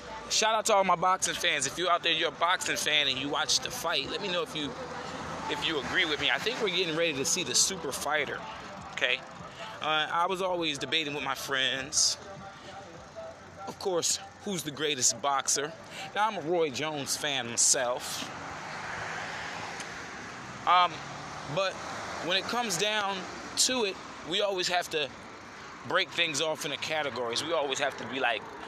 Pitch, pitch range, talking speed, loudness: 160 Hz, 145-185 Hz, 180 wpm, -29 LUFS